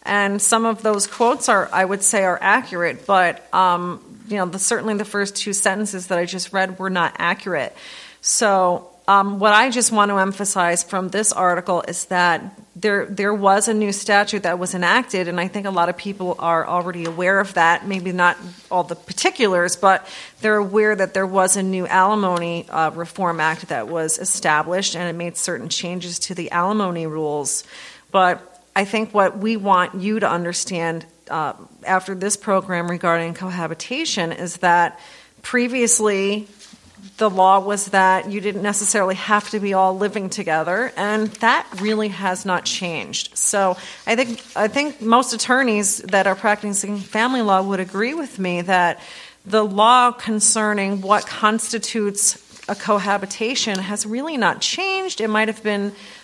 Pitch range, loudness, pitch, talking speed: 180-215 Hz, -19 LUFS, 195 Hz, 170 wpm